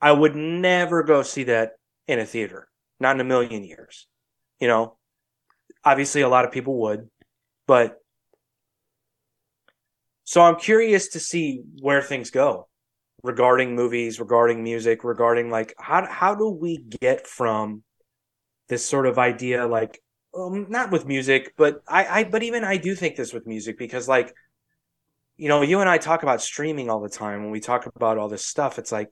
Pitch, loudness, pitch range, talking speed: 125 Hz, -22 LUFS, 115-160 Hz, 175 wpm